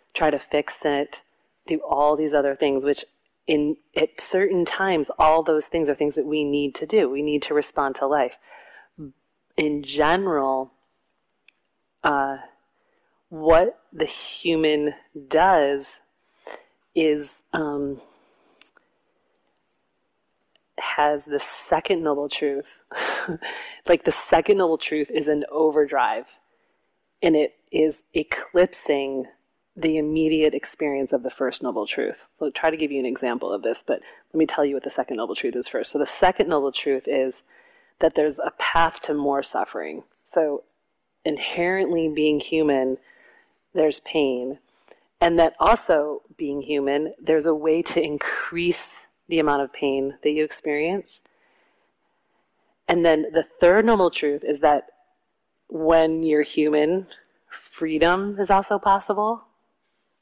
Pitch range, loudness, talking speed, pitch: 145-170 Hz, -23 LUFS, 135 wpm, 155 Hz